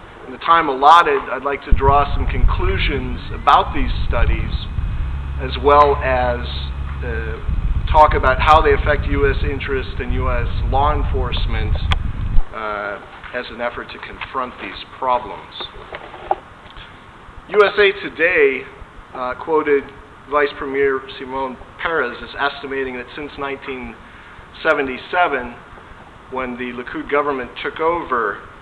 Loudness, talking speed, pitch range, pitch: -18 LUFS, 115 wpm, 85-145 Hz, 130 Hz